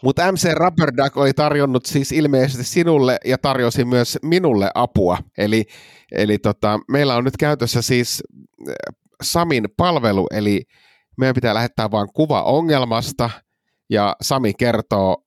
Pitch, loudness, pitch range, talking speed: 130 Hz, -18 LUFS, 110-145 Hz, 135 wpm